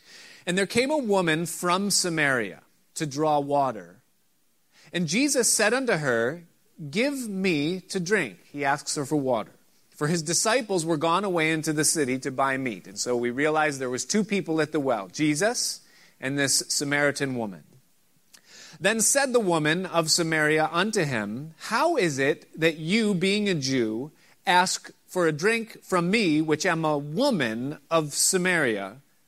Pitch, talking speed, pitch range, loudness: 165 Hz, 165 wpm, 145-195 Hz, -25 LUFS